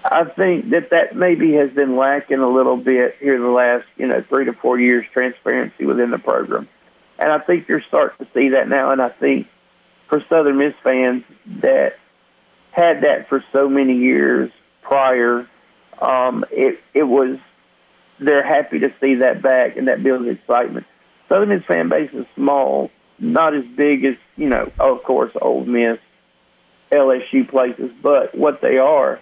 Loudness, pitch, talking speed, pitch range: -17 LUFS, 135 Hz, 175 wpm, 125-145 Hz